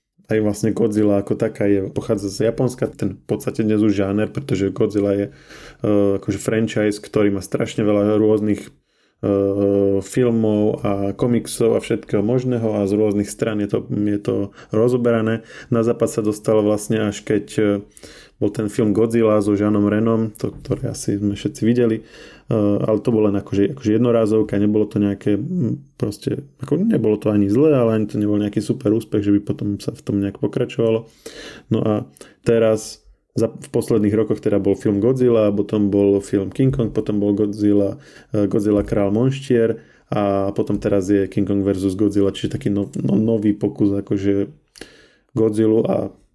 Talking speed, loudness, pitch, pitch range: 175 wpm, -19 LUFS, 105 Hz, 100-115 Hz